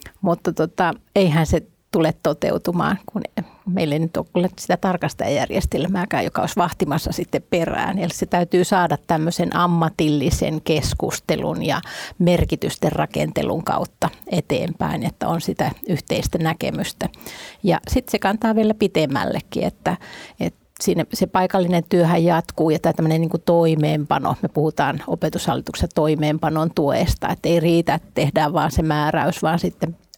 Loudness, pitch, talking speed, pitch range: -21 LUFS, 170 Hz, 135 wpm, 160-185 Hz